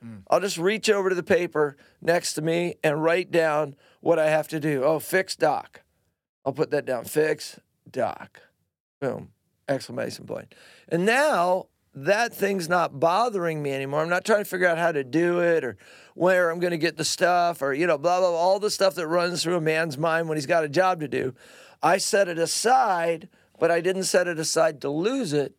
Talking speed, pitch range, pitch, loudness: 215 wpm, 155-185 Hz, 170 Hz, -24 LUFS